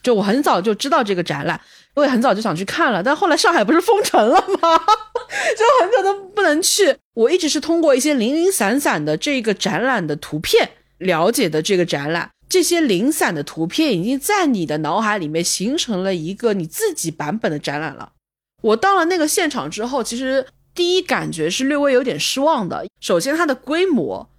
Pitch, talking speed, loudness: 265 Hz, 305 characters per minute, -18 LUFS